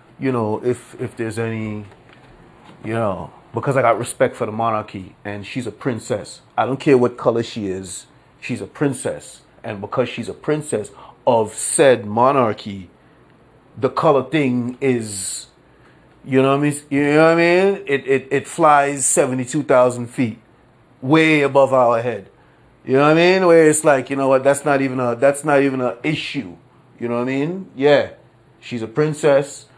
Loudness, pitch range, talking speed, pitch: -18 LUFS, 120-145 Hz, 185 wpm, 135 Hz